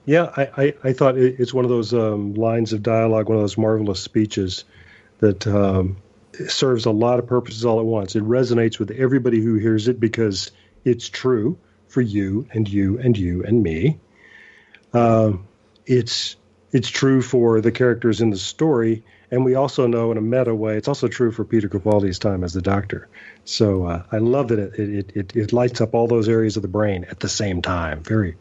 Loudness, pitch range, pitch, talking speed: -20 LUFS, 105-120 Hz, 110 Hz, 205 wpm